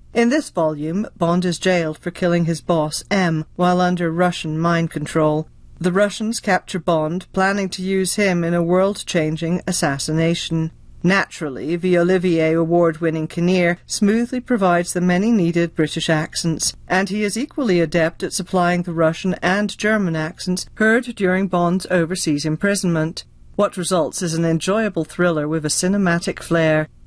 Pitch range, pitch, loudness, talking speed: 165-190 Hz, 175 Hz, -19 LUFS, 150 wpm